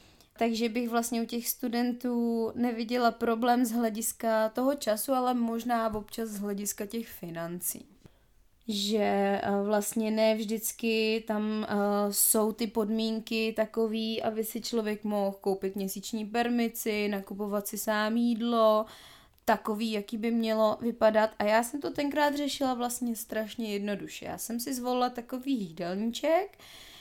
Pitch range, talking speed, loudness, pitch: 215-235 Hz, 130 wpm, -30 LUFS, 225 Hz